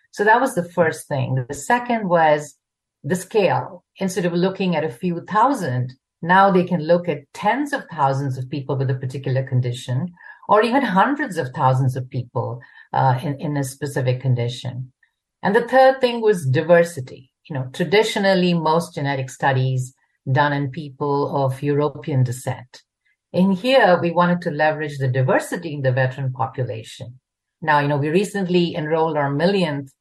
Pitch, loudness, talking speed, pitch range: 150 Hz, -20 LUFS, 165 wpm, 130-180 Hz